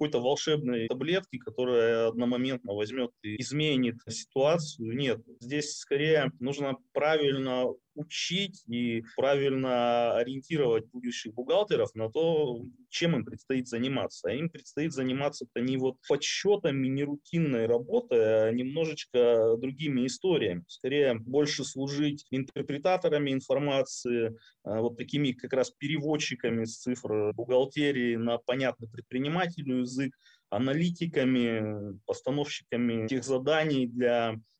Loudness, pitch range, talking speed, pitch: -30 LUFS, 120-145 Hz, 110 wpm, 130 Hz